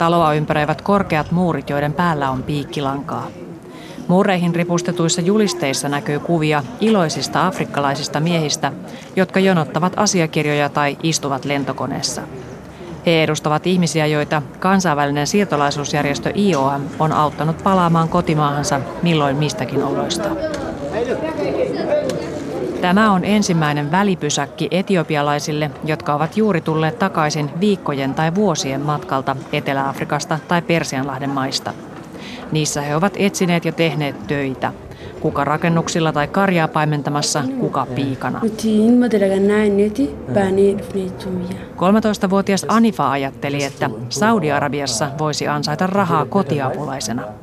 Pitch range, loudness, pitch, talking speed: 145-185 Hz, -18 LUFS, 155 Hz, 95 wpm